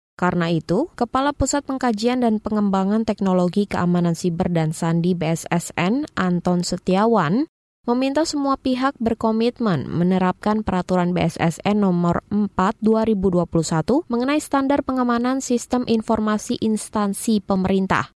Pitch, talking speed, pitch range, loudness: 210 Hz, 100 wpm, 180-240 Hz, -21 LUFS